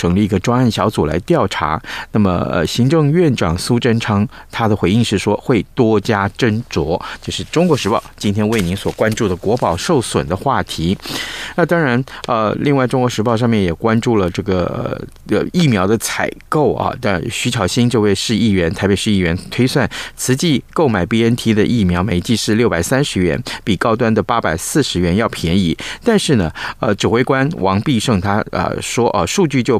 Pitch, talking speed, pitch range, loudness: 110 Hz, 285 characters per minute, 100-120 Hz, -16 LUFS